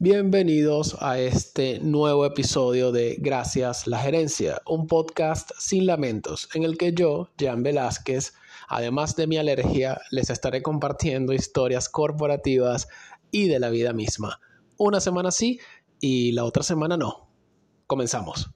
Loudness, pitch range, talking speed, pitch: -24 LUFS, 125-160 Hz, 135 wpm, 145 Hz